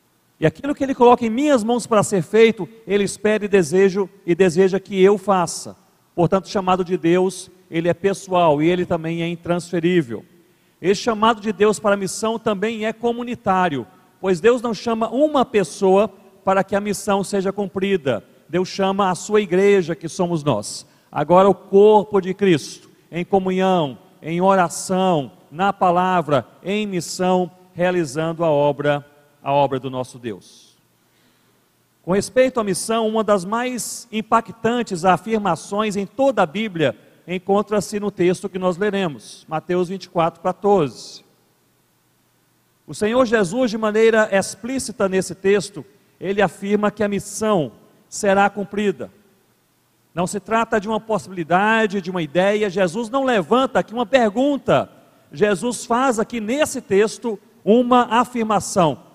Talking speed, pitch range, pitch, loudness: 145 wpm, 180-215 Hz, 195 Hz, -19 LUFS